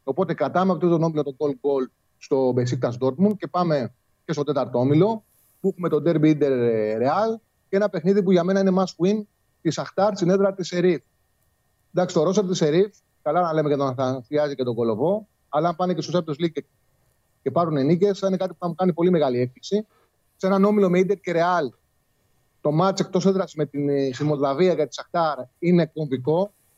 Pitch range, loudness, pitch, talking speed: 140-185 Hz, -22 LUFS, 165 Hz, 205 wpm